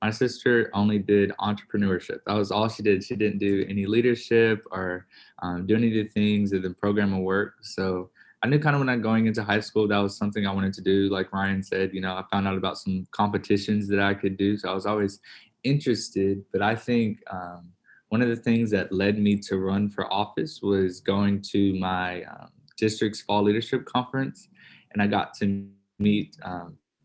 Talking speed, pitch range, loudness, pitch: 210 wpm, 95-110 Hz, -25 LUFS, 100 Hz